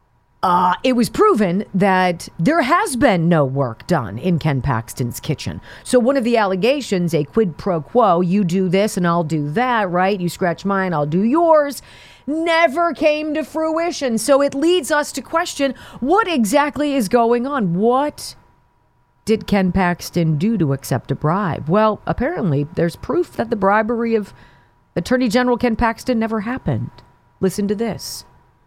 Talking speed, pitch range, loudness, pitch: 165 wpm, 160-255 Hz, -18 LUFS, 200 Hz